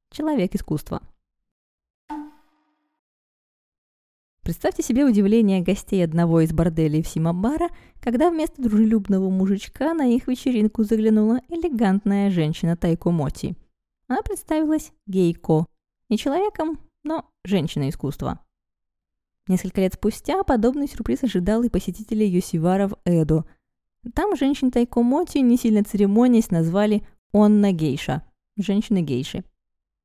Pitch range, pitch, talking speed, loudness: 170-255 Hz, 210 Hz, 105 wpm, -21 LUFS